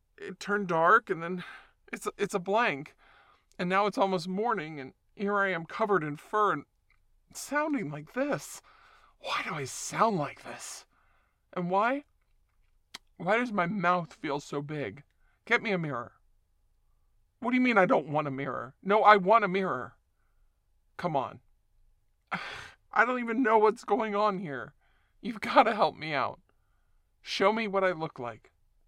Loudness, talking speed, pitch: -29 LUFS, 165 wpm, 180 Hz